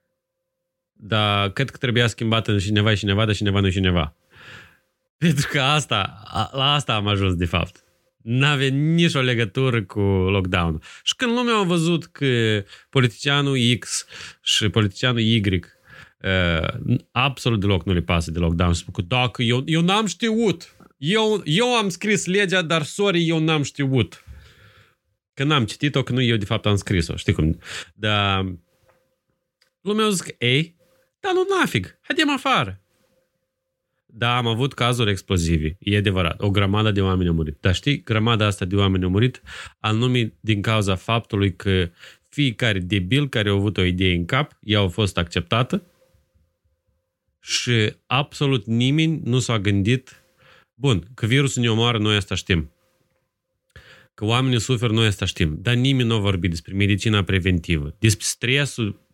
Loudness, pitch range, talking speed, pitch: -21 LUFS, 100-145 Hz, 160 wpm, 115 Hz